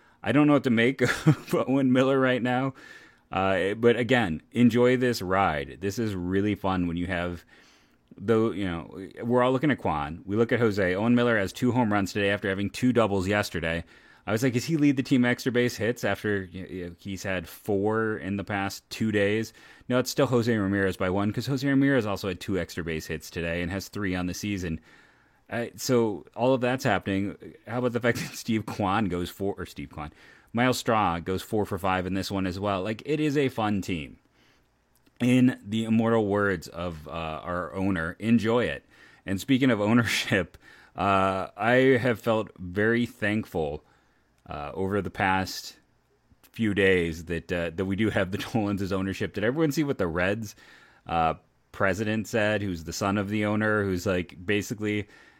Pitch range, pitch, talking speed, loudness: 95-120 Hz, 105 Hz, 200 wpm, -26 LUFS